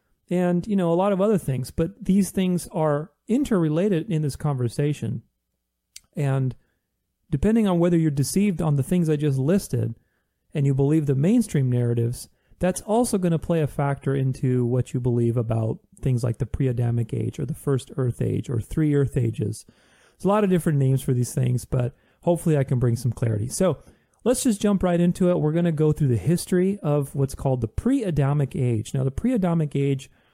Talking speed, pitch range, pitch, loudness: 200 wpm, 125-175 Hz, 145 Hz, -23 LUFS